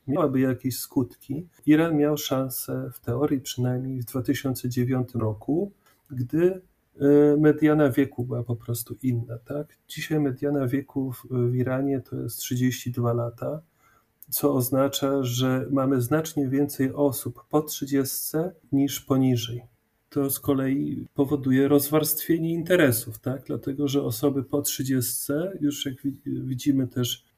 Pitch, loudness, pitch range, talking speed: 135 Hz, -25 LUFS, 125-145 Hz, 125 wpm